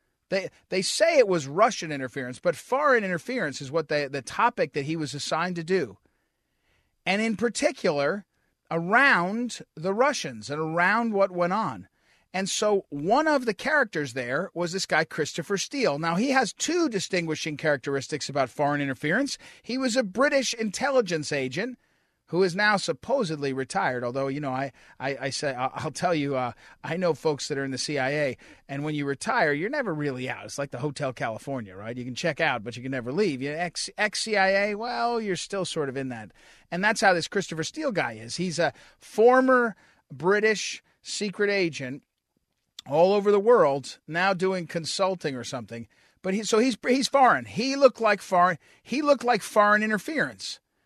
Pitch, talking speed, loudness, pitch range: 175 Hz, 185 wpm, -26 LUFS, 140-215 Hz